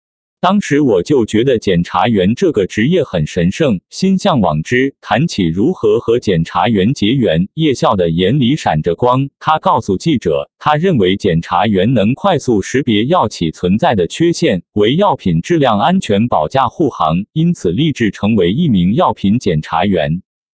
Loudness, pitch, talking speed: -13 LUFS, 150 Hz, 250 characters per minute